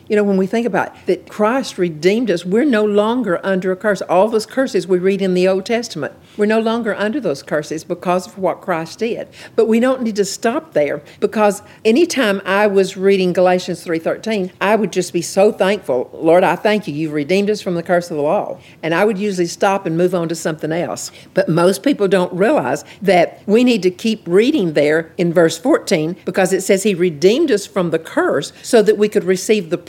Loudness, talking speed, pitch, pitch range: -16 LUFS, 225 wpm, 190 Hz, 175-210 Hz